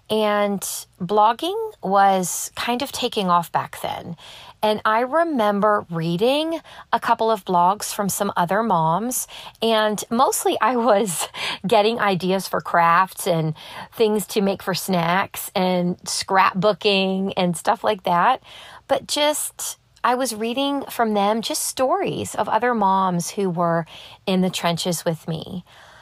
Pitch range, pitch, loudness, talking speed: 185-230 Hz, 205 Hz, -21 LUFS, 140 wpm